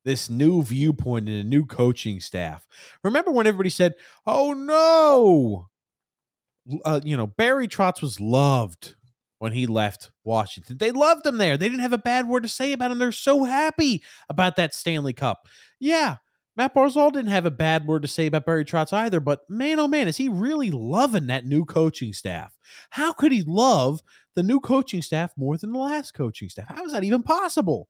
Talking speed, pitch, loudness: 195 wpm, 170 Hz, -22 LUFS